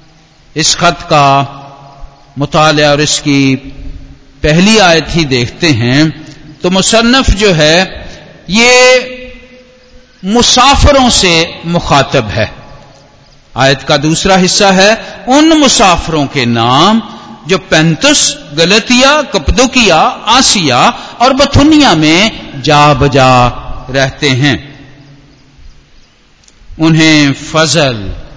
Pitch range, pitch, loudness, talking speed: 140-205 Hz, 155 Hz, -7 LUFS, 90 wpm